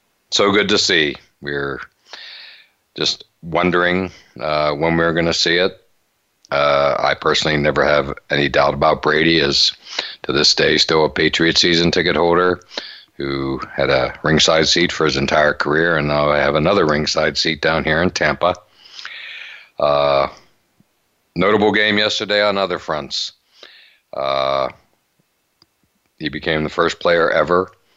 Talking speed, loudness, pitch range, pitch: 145 wpm, -16 LUFS, 70-90 Hz, 75 Hz